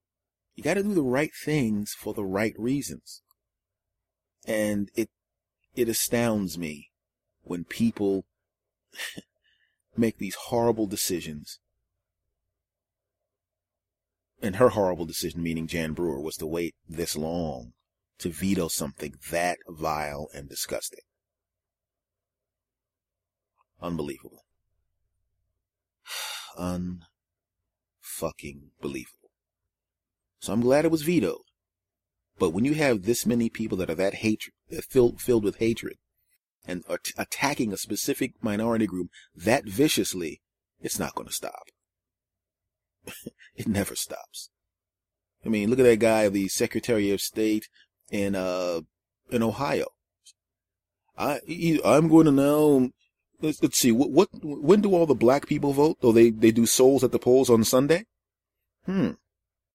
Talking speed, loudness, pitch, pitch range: 125 wpm, -25 LUFS, 100 Hz, 90-115 Hz